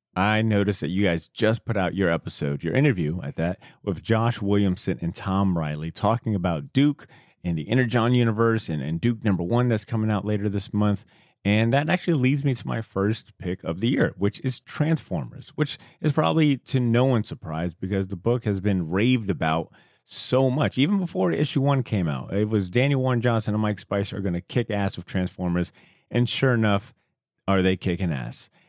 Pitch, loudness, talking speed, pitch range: 105 Hz, -24 LUFS, 205 wpm, 95-125 Hz